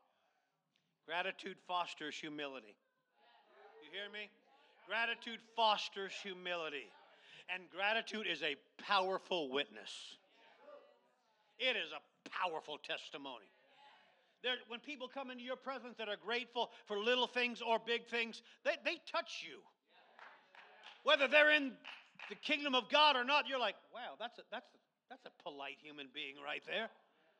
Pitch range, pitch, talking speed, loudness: 180-255 Hz, 225 Hz, 140 wpm, -38 LUFS